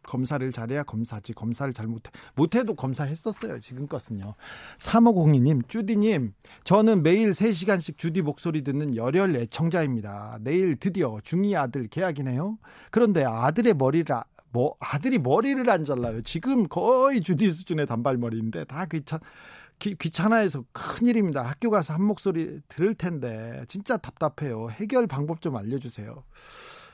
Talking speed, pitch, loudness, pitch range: 335 characters per minute, 160 Hz, -25 LUFS, 130-205 Hz